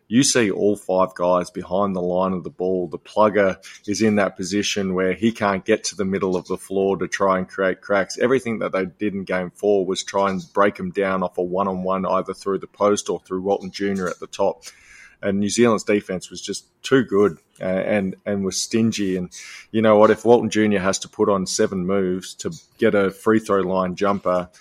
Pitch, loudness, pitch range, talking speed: 95 Hz, -21 LUFS, 95-105 Hz, 225 wpm